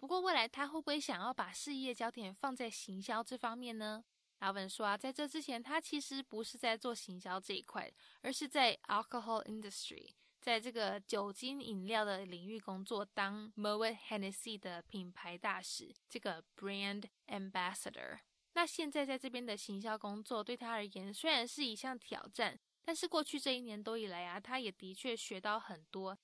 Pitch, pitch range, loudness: 225 Hz, 200-260 Hz, -41 LUFS